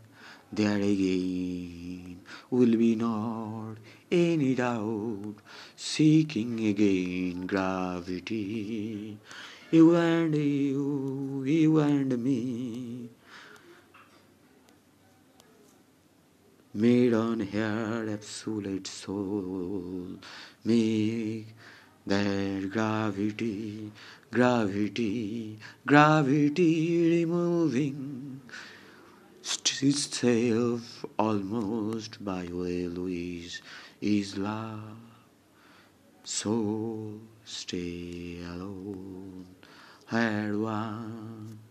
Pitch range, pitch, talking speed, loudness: 100-125 Hz, 110 Hz, 60 wpm, -28 LUFS